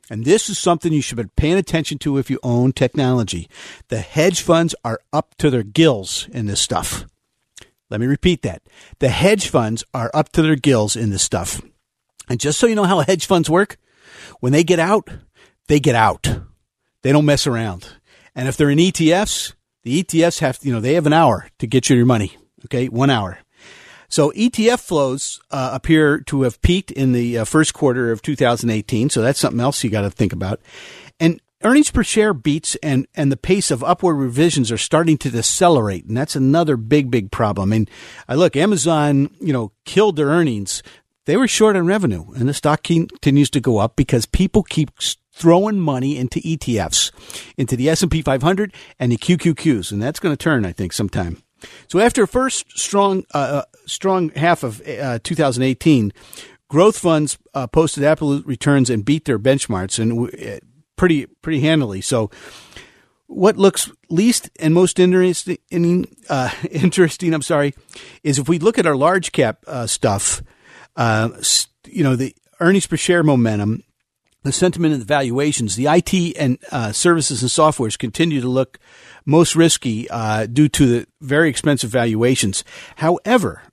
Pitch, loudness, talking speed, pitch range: 145 Hz, -17 LUFS, 185 wpm, 120-170 Hz